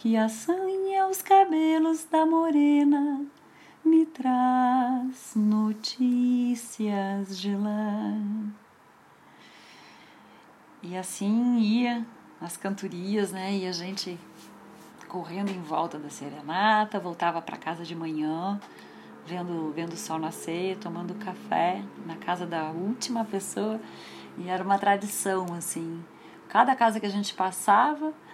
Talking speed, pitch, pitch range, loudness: 110 wpm, 205 Hz, 180-250 Hz, -27 LUFS